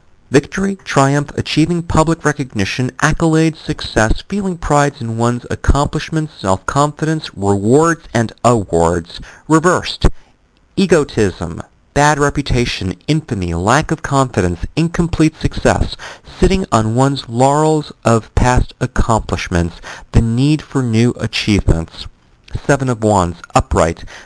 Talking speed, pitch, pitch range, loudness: 105 wpm, 125 Hz, 100-150 Hz, -15 LUFS